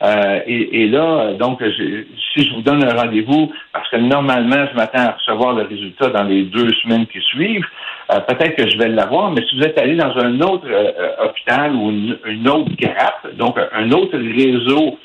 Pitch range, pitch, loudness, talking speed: 110-145 Hz, 125 Hz, -15 LUFS, 205 wpm